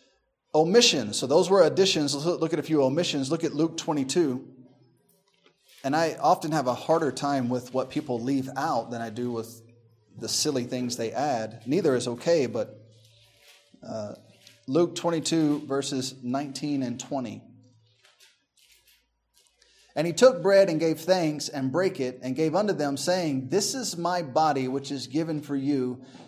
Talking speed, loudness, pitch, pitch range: 160 wpm, -26 LUFS, 140 Hz, 125-160 Hz